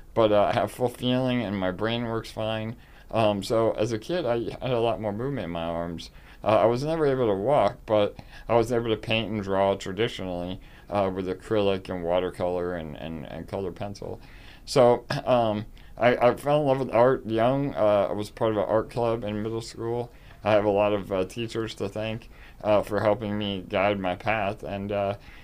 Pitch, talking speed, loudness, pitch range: 105 Hz, 210 wpm, -26 LUFS, 100-115 Hz